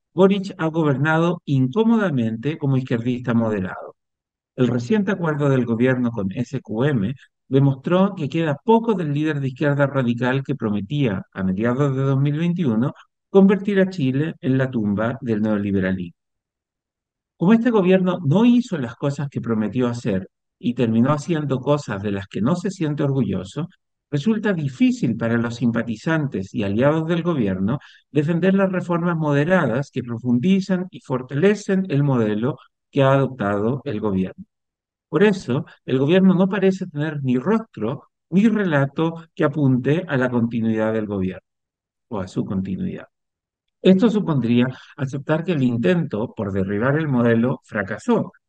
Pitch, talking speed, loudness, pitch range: 135 Hz, 140 wpm, -21 LUFS, 120-170 Hz